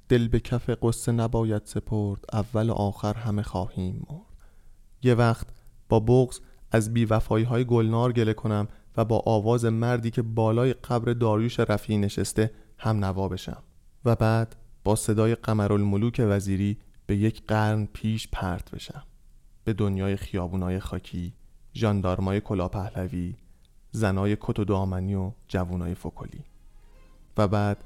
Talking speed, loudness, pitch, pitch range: 140 wpm, -26 LUFS, 110 Hz, 100-115 Hz